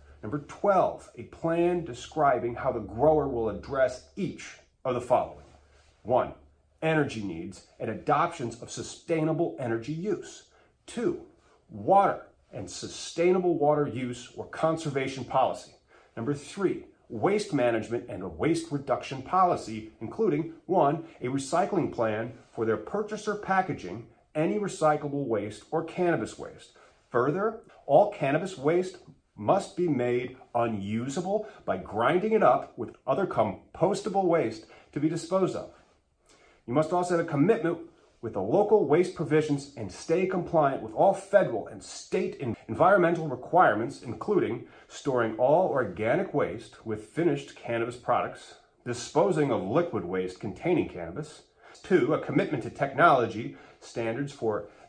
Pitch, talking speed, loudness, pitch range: 145 Hz, 130 wpm, -28 LUFS, 115-170 Hz